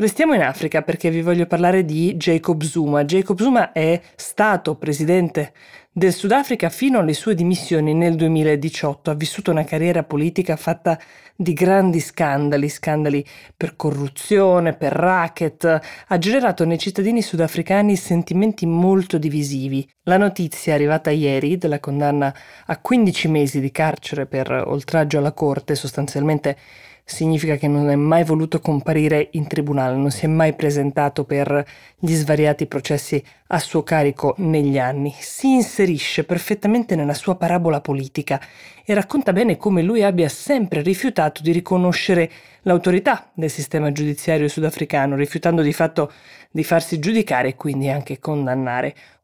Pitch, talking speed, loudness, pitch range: 160 Hz, 140 wpm, -19 LUFS, 145-180 Hz